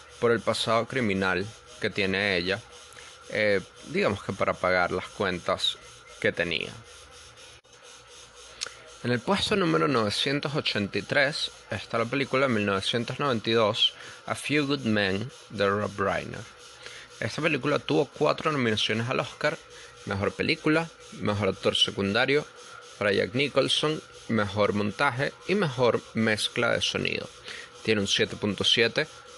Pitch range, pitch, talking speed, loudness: 105-150 Hz, 120 Hz, 120 wpm, -26 LUFS